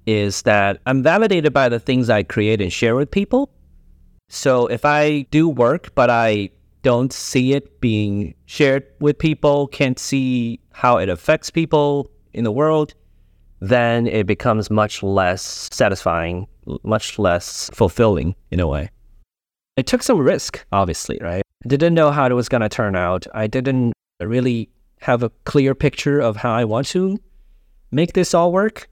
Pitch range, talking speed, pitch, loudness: 105-145 Hz, 165 wpm, 120 Hz, -18 LUFS